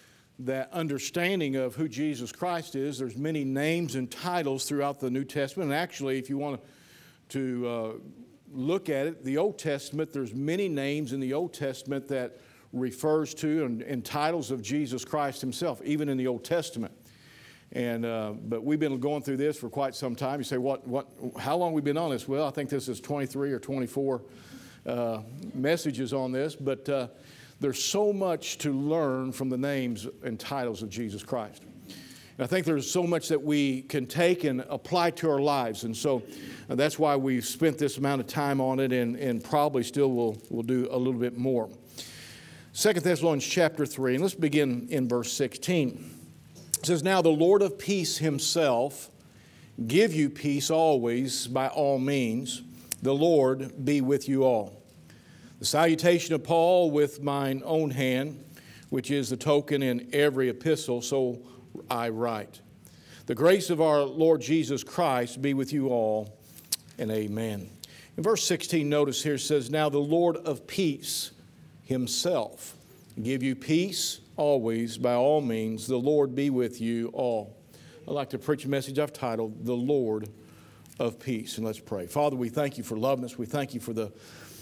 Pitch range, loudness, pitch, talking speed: 125-155 Hz, -28 LUFS, 140 Hz, 180 wpm